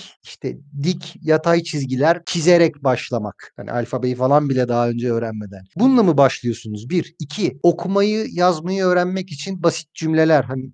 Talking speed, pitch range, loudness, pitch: 140 wpm, 130-175 Hz, -19 LUFS, 160 Hz